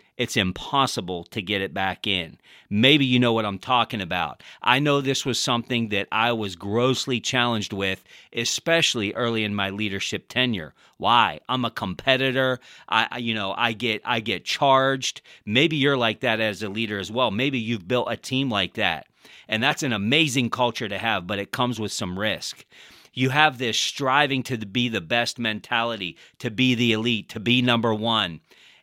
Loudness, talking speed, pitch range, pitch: -23 LUFS, 185 wpm, 105-125 Hz, 115 Hz